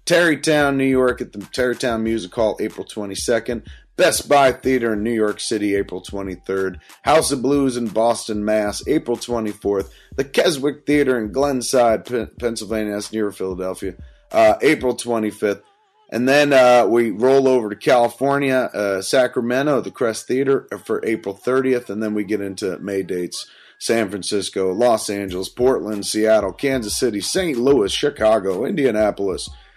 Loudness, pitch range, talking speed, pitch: -19 LUFS, 100-130 Hz, 150 wpm, 115 Hz